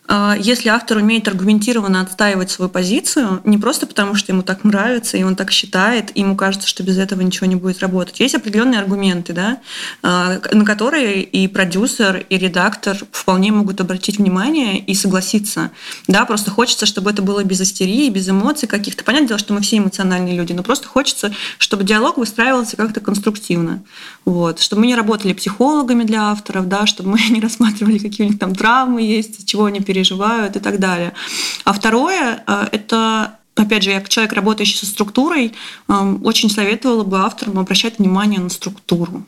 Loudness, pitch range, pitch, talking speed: -15 LUFS, 190-225 Hz, 210 Hz, 175 wpm